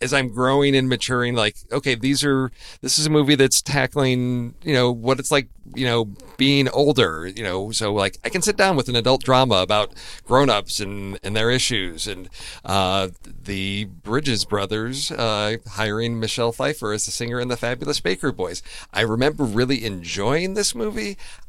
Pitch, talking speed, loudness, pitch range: 120 Hz, 180 wpm, -21 LUFS, 105-135 Hz